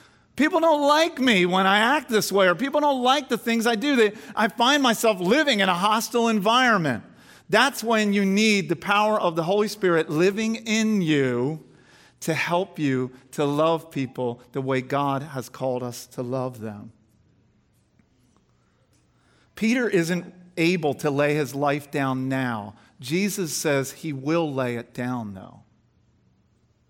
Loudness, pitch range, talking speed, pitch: -22 LUFS, 135-220 Hz, 160 wpm, 170 Hz